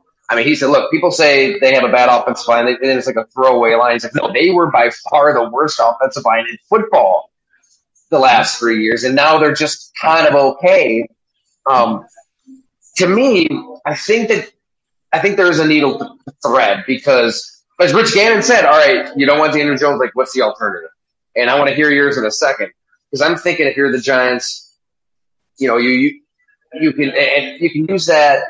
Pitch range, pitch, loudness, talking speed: 130-210 Hz, 145 Hz, -13 LUFS, 205 wpm